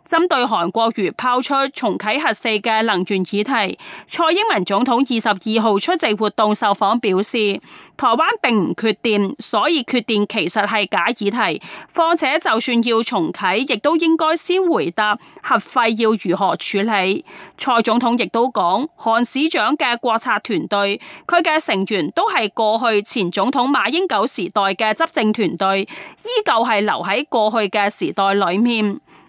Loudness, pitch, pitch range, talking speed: -18 LUFS, 225 Hz, 205-265 Hz, 240 characters per minute